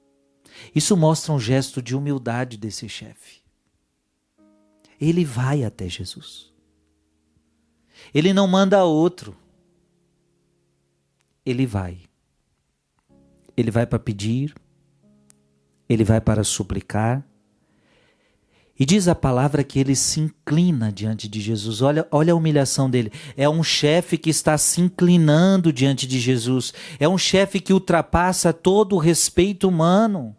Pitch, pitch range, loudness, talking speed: 135 Hz, 105-170 Hz, -20 LUFS, 120 wpm